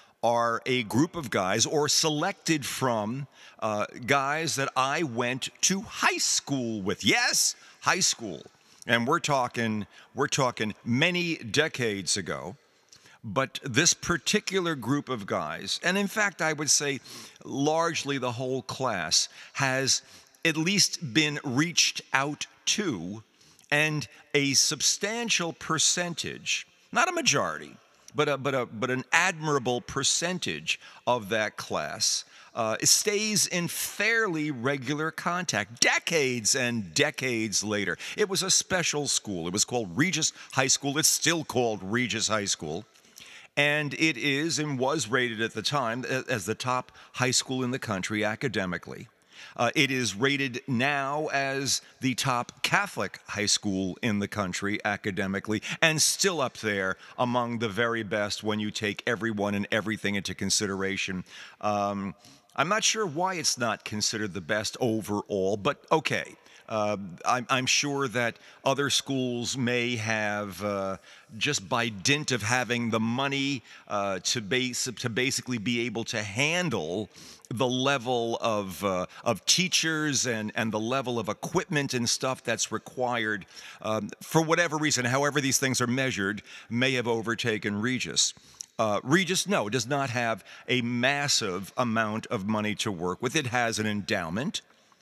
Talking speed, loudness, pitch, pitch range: 145 wpm, -27 LUFS, 125 Hz, 110-150 Hz